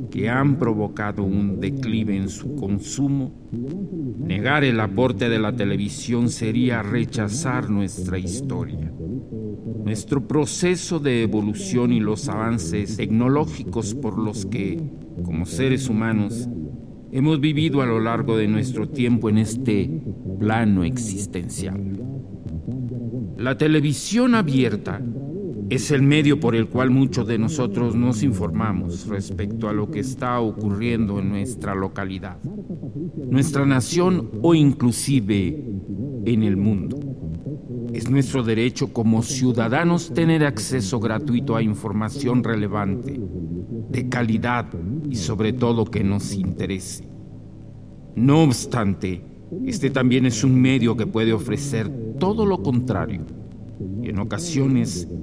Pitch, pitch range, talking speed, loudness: 115 Hz, 105-135 Hz, 120 wpm, -22 LUFS